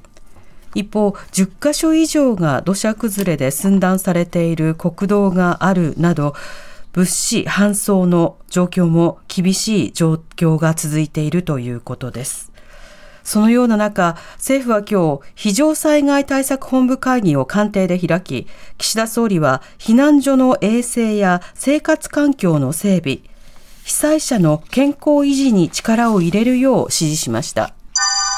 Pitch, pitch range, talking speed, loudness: 190 Hz, 160-240 Hz, 255 characters per minute, -16 LUFS